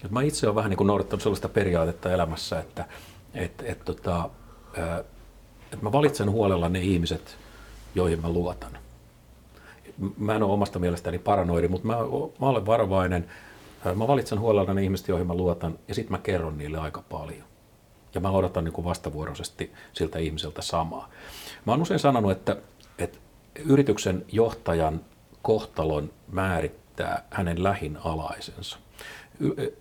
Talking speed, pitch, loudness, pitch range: 145 wpm, 95 Hz, -27 LUFS, 85-110 Hz